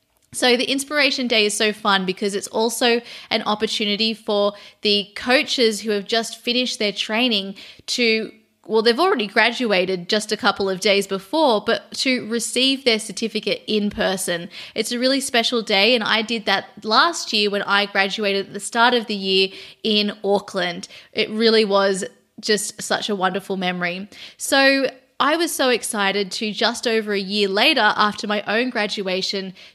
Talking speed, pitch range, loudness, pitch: 170 wpm, 200-235 Hz, -19 LUFS, 215 Hz